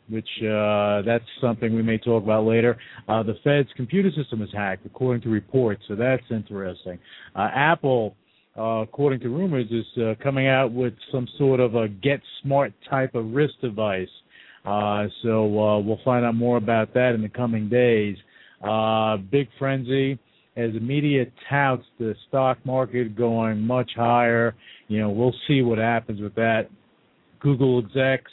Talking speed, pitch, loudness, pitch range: 165 wpm, 115 Hz, -23 LUFS, 110-130 Hz